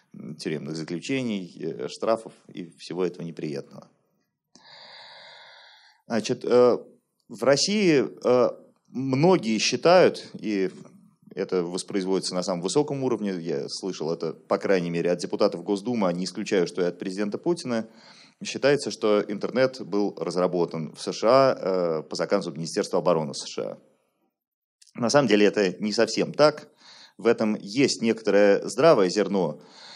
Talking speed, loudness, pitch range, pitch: 125 wpm, -24 LUFS, 95-130 Hz, 110 Hz